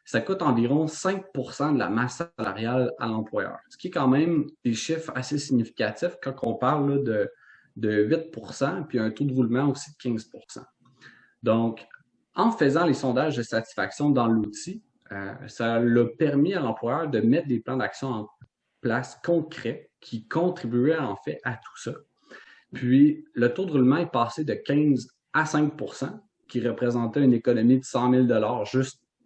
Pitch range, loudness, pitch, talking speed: 120-150 Hz, -25 LUFS, 130 Hz, 170 wpm